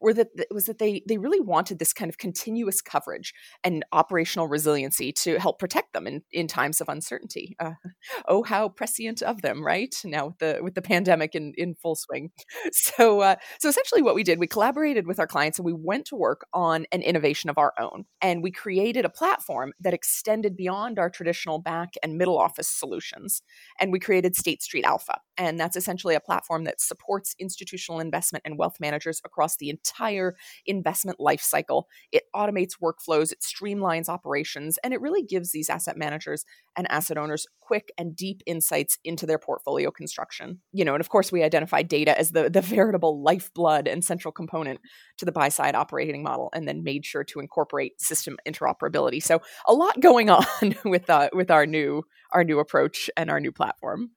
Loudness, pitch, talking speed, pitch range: -25 LUFS, 175 Hz, 195 wpm, 160-200 Hz